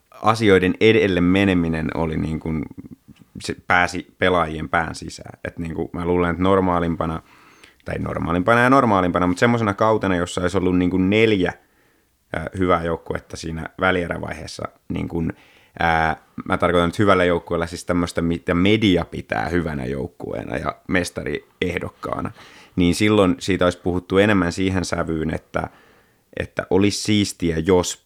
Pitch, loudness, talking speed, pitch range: 90 Hz, -20 LUFS, 135 wpm, 85-95 Hz